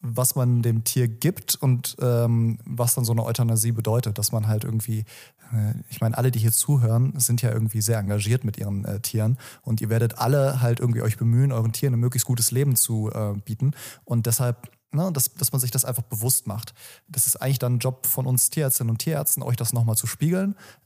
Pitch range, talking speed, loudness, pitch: 115-130 Hz, 220 wpm, -23 LUFS, 120 Hz